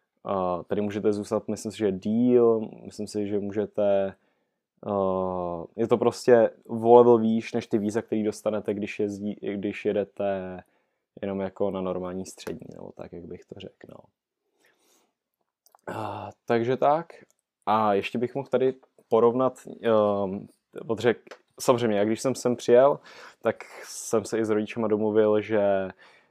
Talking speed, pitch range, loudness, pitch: 150 wpm, 100-115 Hz, -25 LUFS, 105 Hz